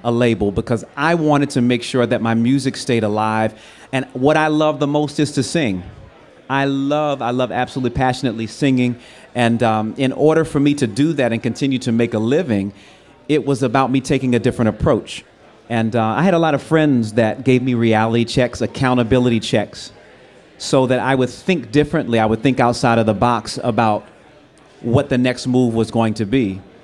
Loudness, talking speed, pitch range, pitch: -17 LUFS, 200 wpm, 115-135 Hz, 125 Hz